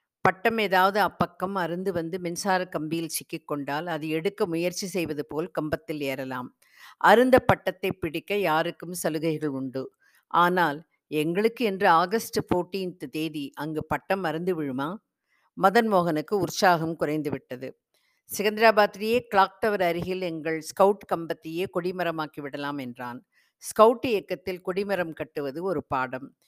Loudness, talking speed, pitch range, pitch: -26 LUFS, 120 wpm, 155-190 Hz, 170 Hz